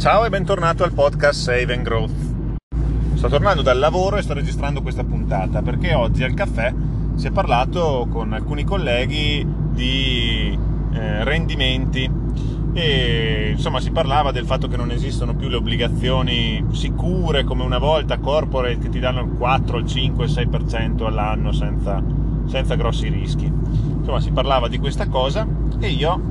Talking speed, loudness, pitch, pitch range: 155 wpm, -20 LUFS, 140 Hz, 130-150 Hz